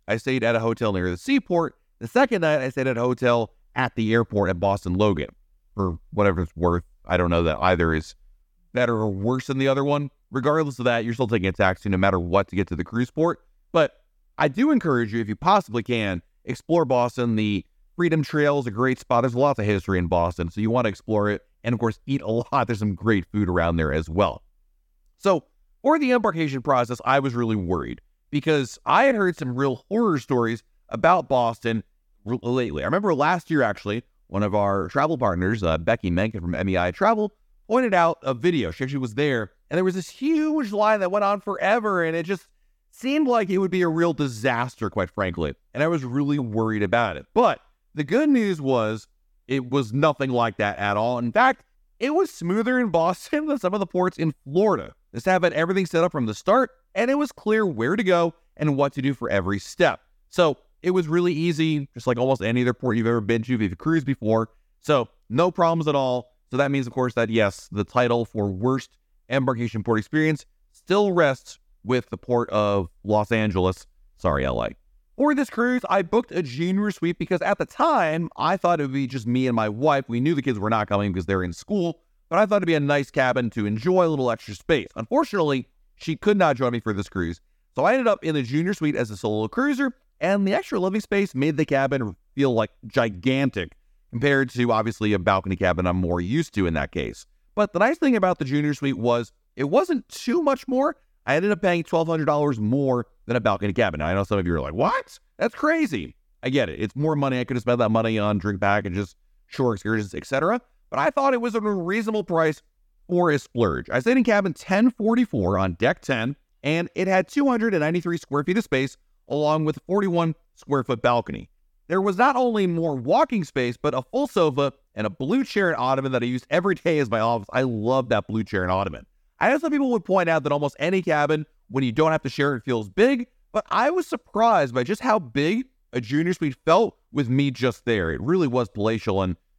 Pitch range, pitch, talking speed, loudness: 105-175 Hz, 130 Hz, 225 wpm, -23 LUFS